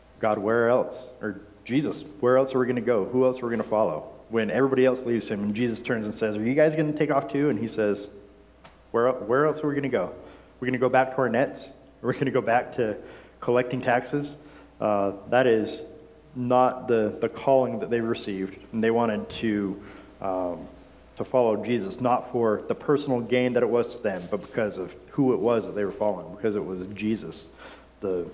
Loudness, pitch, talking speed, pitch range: -26 LUFS, 120 Hz, 230 wpm, 105-130 Hz